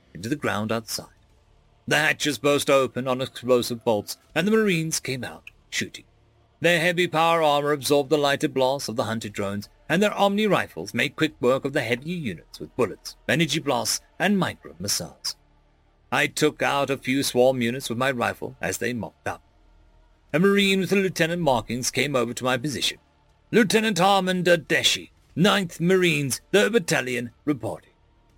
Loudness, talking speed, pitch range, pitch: -23 LUFS, 170 wpm, 115-165 Hz, 140 Hz